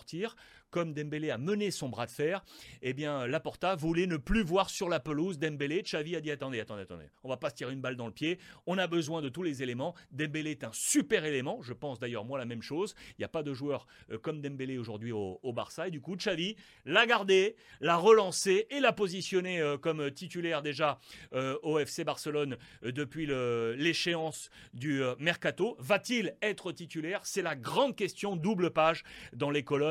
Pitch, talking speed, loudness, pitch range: 155 Hz, 195 wpm, -33 LUFS, 135-180 Hz